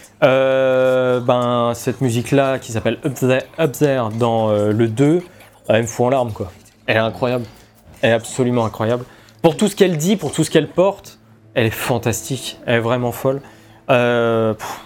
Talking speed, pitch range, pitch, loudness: 185 wpm, 110-135 Hz, 120 Hz, -18 LUFS